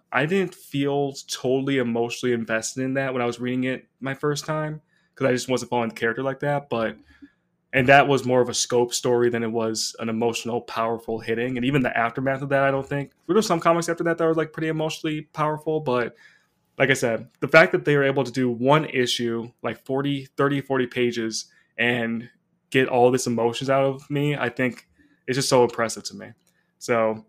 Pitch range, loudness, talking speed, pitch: 120-145 Hz, -23 LUFS, 215 wpm, 130 Hz